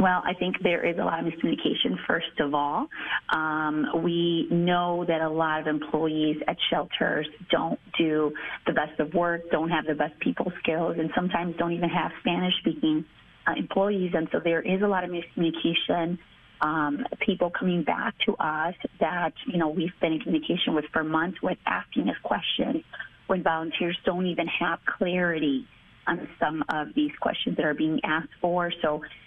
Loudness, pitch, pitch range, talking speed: -27 LUFS, 170 Hz, 160-180 Hz, 180 wpm